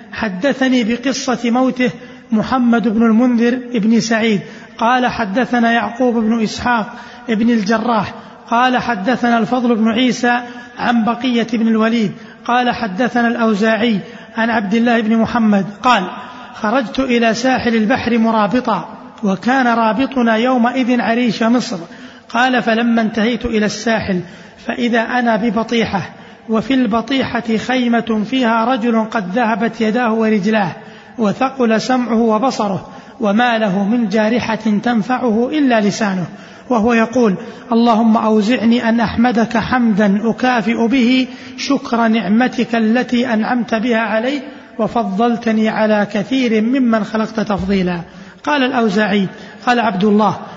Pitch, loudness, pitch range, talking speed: 230 Hz, -15 LUFS, 220-245 Hz, 115 wpm